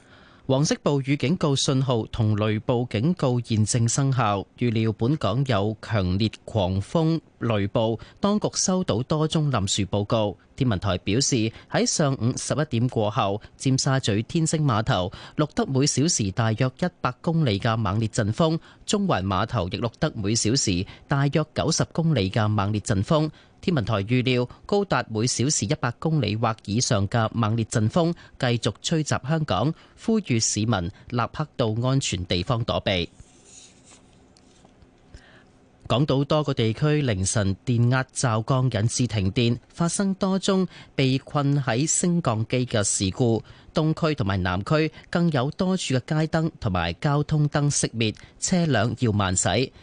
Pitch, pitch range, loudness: 125 Hz, 110-150 Hz, -24 LUFS